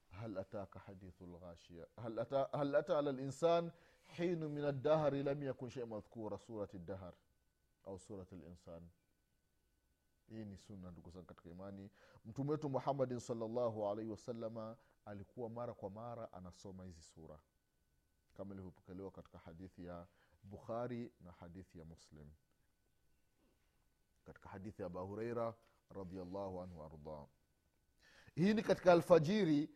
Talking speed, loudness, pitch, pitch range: 95 wpm, -41 LUFS, 100 Hz, 90-125 Hz